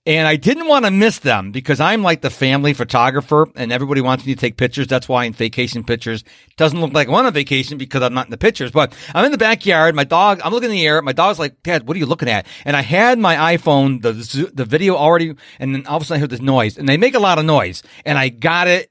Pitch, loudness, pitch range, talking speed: 145 Hz, -15 LUFS, 130-165 Hz, 285 wpm